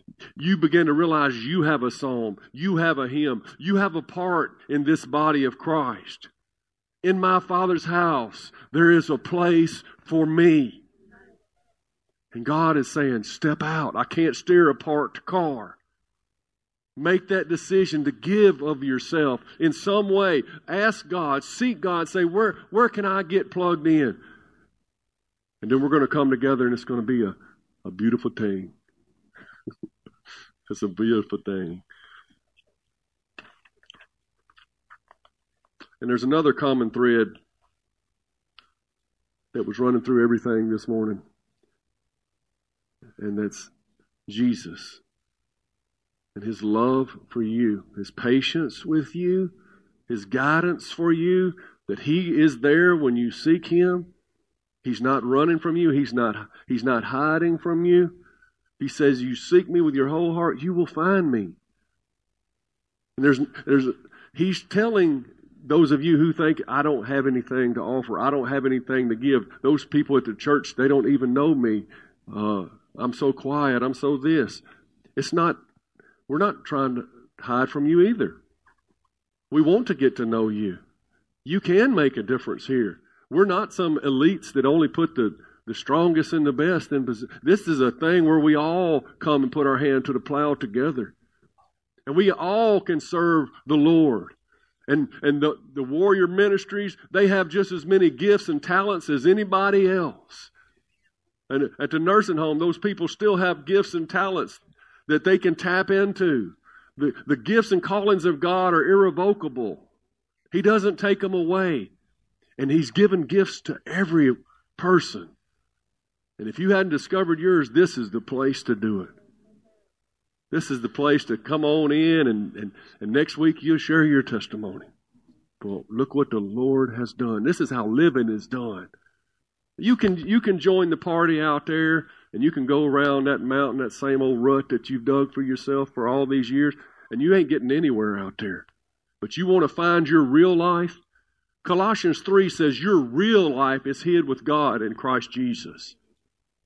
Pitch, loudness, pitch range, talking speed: 150 Hz, -22 LUFS, 130-180 Hz, 165 wpm